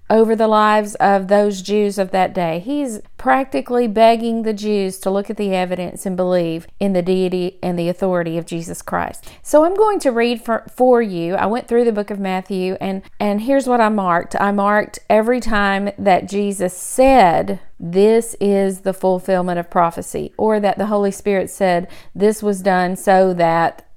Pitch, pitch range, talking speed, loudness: 200 Hz, 185-220 Hz, 190 wpm, -17 LUFS